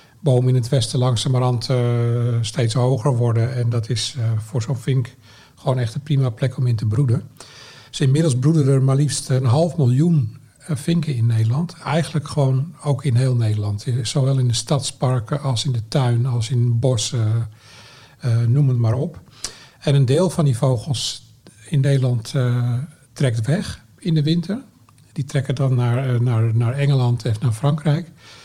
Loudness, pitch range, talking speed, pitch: -20 LUFS, 120-145 Hz, 185 wpm, 130 Hz